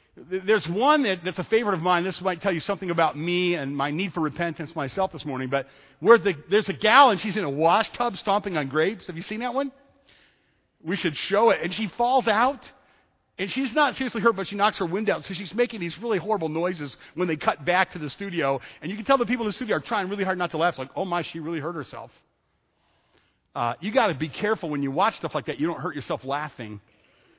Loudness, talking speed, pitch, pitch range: -25 LUFS, 255 wpm, 185 Hz, 155-215 Hz